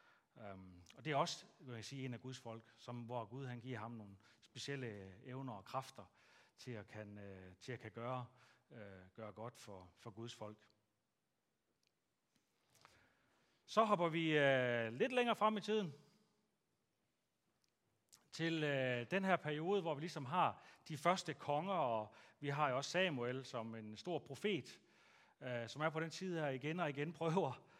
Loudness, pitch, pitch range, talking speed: -42 LUFS, 125 Hz, 110-155 Hz, 175 wpm